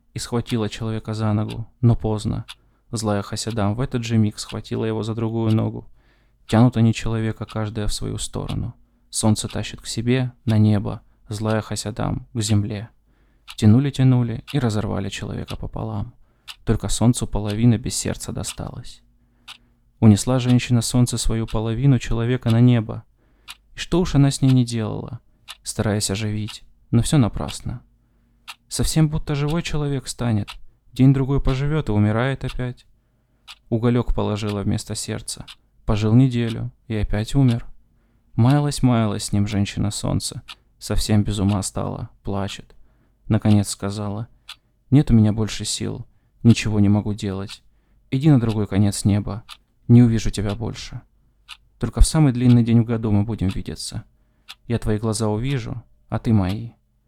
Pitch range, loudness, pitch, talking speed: 105-125 Hz, -21 LUFS, 115 Hz, 140 wpm